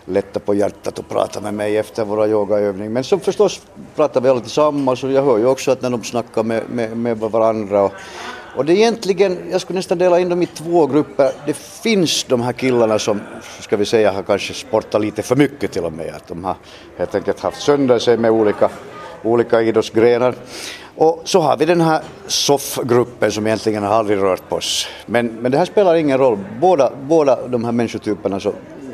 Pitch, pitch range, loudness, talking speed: 120 Hz, 110-150 Hz, -17 LUFS, 210 wpm